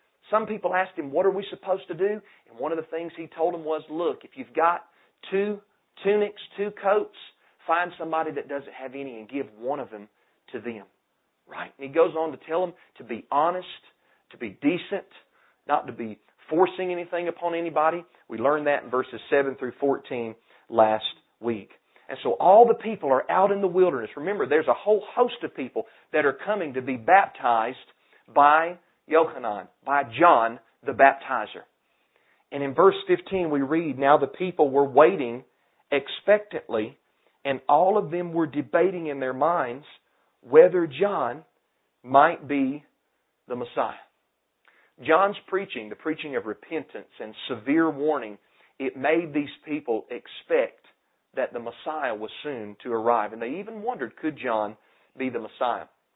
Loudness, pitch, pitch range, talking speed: -25 LUFS, 160 Hz, 135-185 Hz, 170 wpm